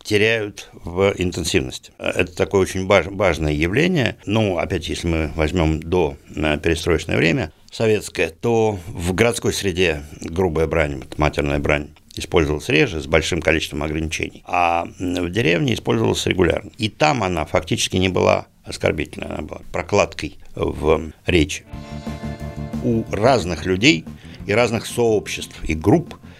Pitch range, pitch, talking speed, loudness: 80-105 Hz, 90 Hz, 125 wpm, -20 LUFS